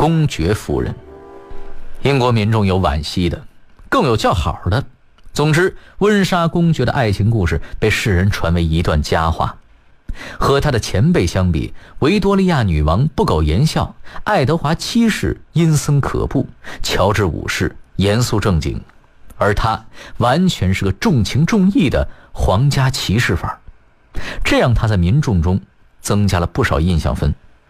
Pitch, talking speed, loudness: 105 Hz, 225 characters per minute, -16 LUFS